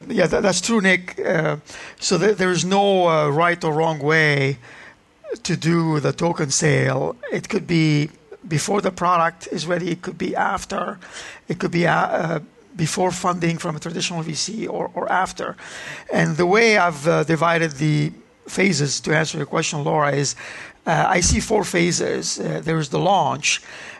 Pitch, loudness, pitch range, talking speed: 170 Hz, -20 LUFS, 155-185 Hz, 170 wpm